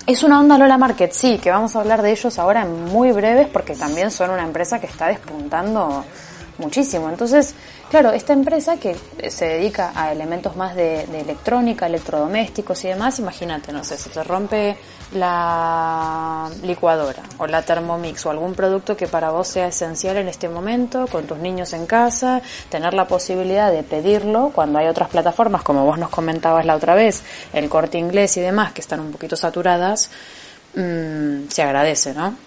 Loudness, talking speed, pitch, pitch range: -18 LUFS, 180 wpm, 180 Hz, 160-215 Hz